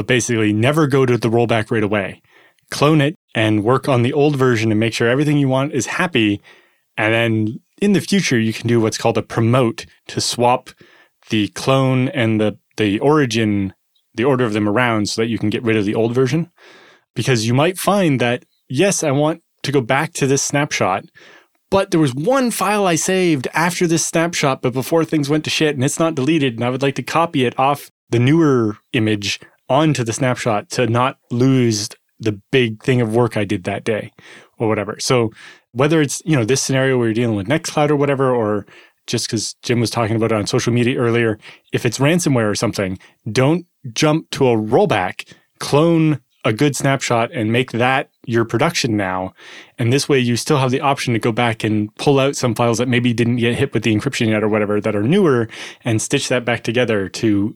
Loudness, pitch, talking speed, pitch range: -17 LUFS, 125 Hz, 210 wpm, 115-145 Hz